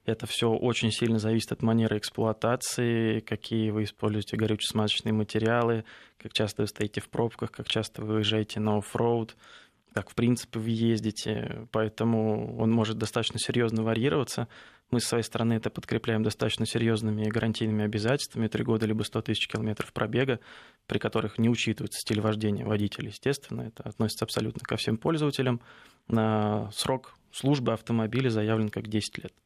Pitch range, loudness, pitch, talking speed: 110-115 Hz, -29 LUFS, 110 Hz, 150 wpm